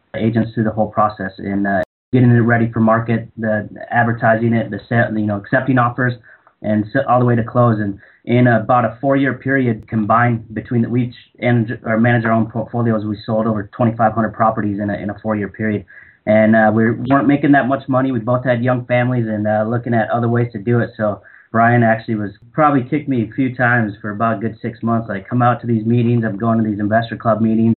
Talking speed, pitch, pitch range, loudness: 235 wpm, 115 Hz, 110-120 Hz, -17 LUFS